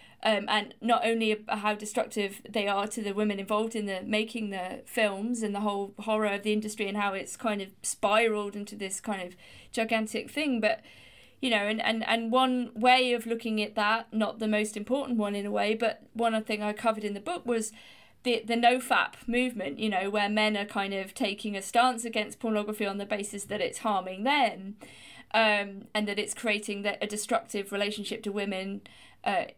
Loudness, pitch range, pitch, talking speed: -29 LUFS, 205-230 Hz, 215 Hz, 205 wpm